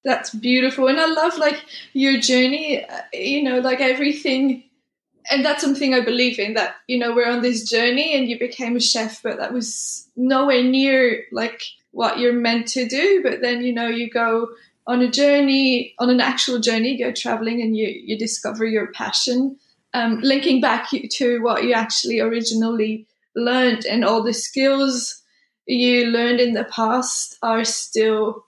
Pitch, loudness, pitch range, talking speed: 245 Hz, -19 LUFS, 230-265 Hz, 175 wpm